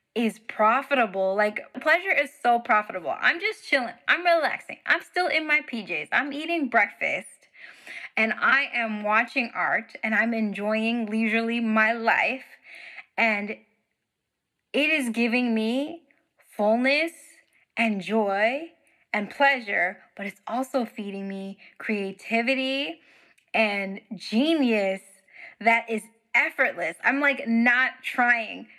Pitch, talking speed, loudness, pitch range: 230 Hz, 115 wpm, -24 LUFS, 215-275 Hz